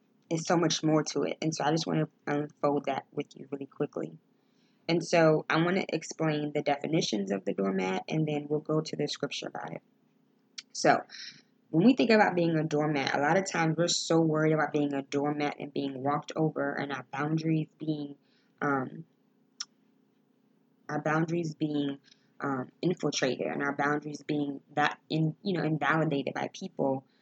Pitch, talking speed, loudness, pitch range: 155 Hz, 180 wpm, -30 LUFS, 145-175 Hz